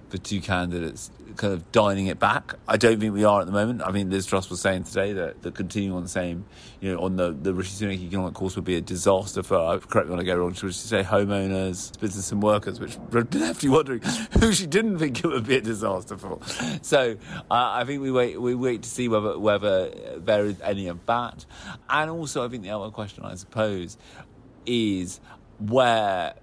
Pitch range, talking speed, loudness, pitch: 95-115 Hz, 220 wpm, -25 LUFS, 100 Hz